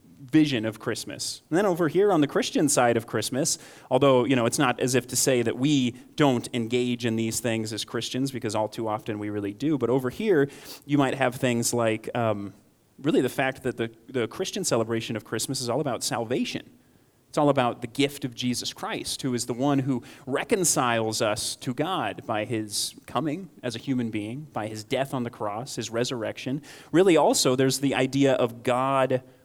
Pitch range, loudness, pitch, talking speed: 115-135 Hz, -26 LUFS, 125 Hz, 205 wpm